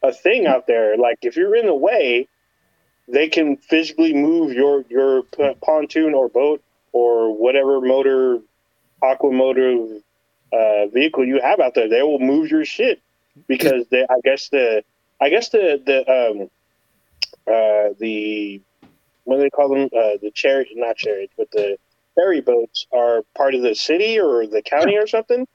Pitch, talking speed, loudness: 140 Hz, 165 wpm, -18 LUFS